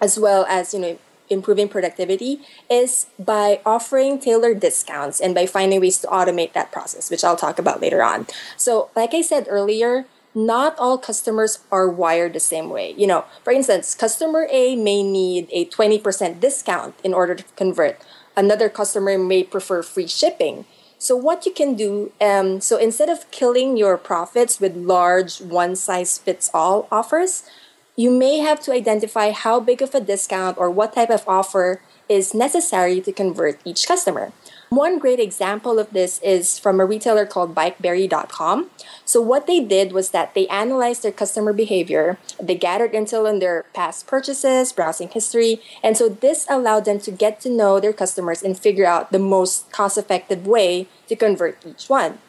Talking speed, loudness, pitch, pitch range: 175 wpm, -19 LUFS, 210 Hz, 190-245 Hz